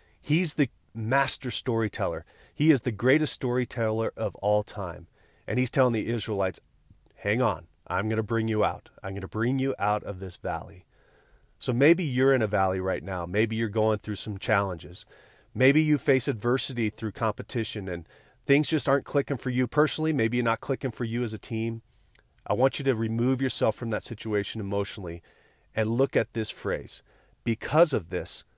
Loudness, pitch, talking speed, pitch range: -27 LUFS, 115 Hz, 185 wpm, 105-130 Hz